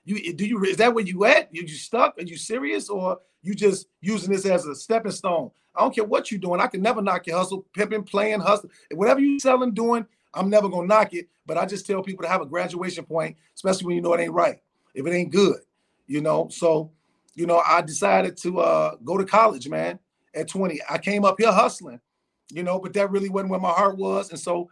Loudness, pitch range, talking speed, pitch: -23 LUFS, 170-205 Hz, 240 wpm, 190 Hz